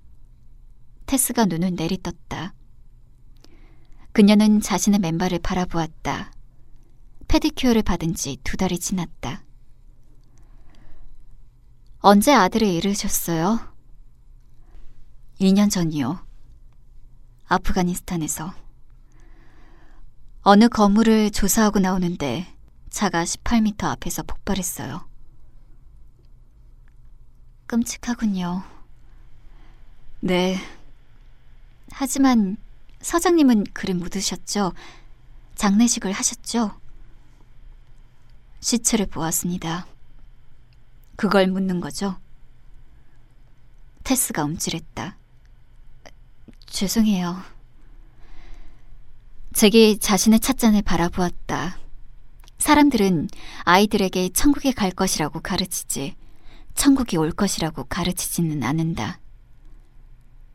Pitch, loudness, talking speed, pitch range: 180 Hz, -21 LUFS, 180 characters per minute, 130-210 Hz